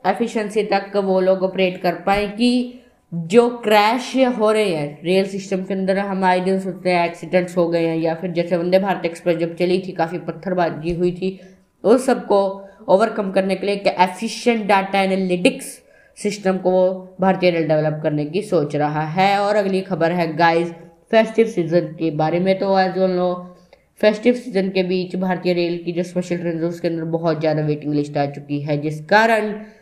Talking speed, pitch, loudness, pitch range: 190 wpm, 185 Hz, -19 LUFS, 170-200 Hz